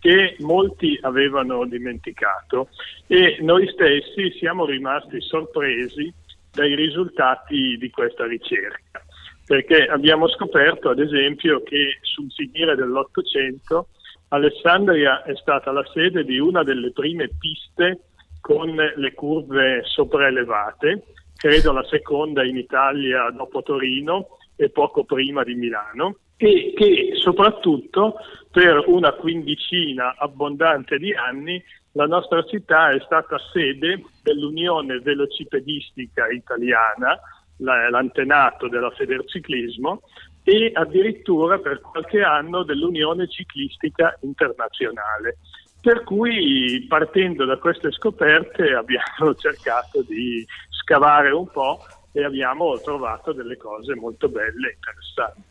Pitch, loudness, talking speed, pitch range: 160 Hz, -19 LUFS, 110 wpm, 135-215 Hz